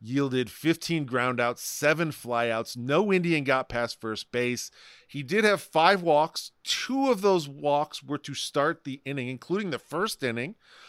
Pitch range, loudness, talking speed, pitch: 125-165 Hz, -27 LUFS, 165 wpm, 145 Hz